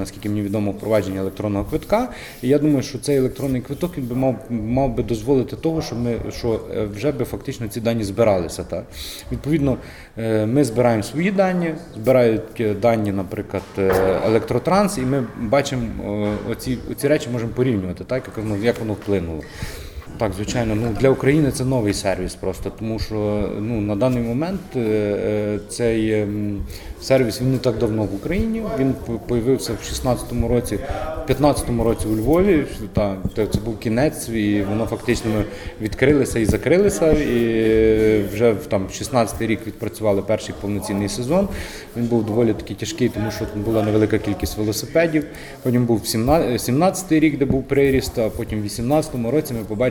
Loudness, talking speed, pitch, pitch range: -21 LUFS, 155 wpm, 115 Hz, 105-130 Hz